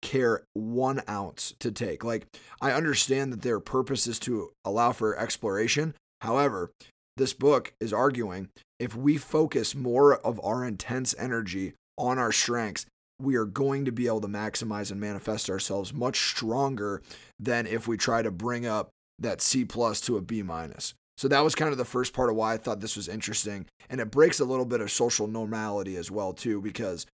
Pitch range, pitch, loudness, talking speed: 105-130 Hz, 115 Hz, -28 LUFS, 190 wpm